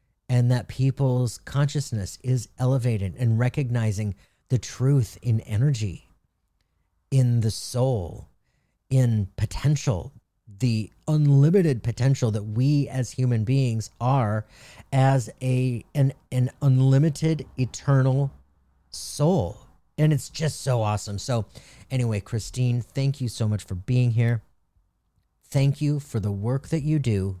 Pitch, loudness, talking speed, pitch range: 125 Hz, -24 LUFS, 125 wpm, 110-135 Hz